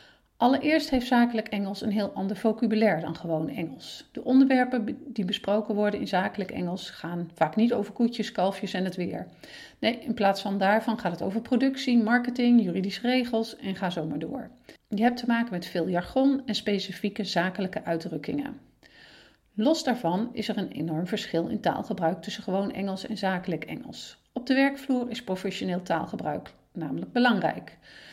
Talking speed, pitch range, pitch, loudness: 170 wpm, 185-240 Hz, 215 Hz, -27 LUFS